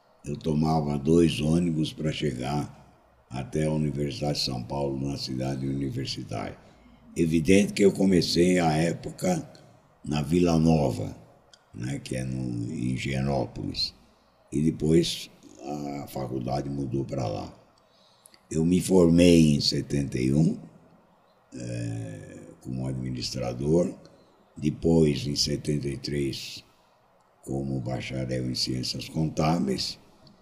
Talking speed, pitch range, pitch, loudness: 105 wpm, 65-80 Hz, 75 Hz, -26 LUFS